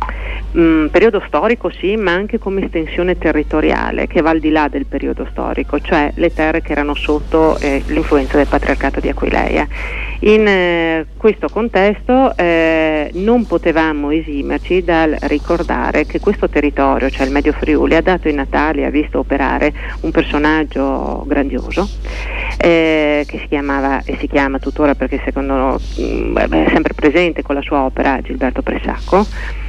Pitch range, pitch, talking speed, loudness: 140-170 Hz, 155 Hz, 155 wpm, -15 LUFS